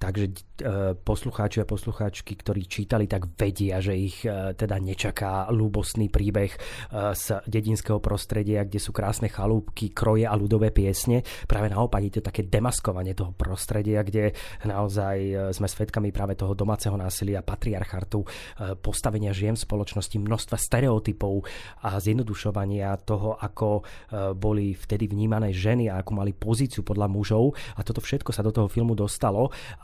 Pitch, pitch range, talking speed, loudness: 105 Hz, 100-110 Hz, 140 wpm, -27 LUFS